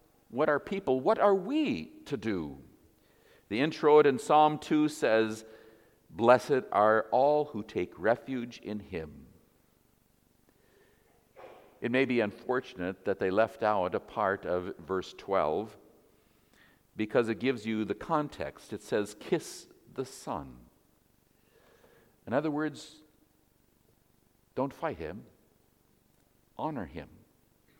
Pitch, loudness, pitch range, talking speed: 125 Hz, -30 LUFS, 110-150 Hz, 115 wpm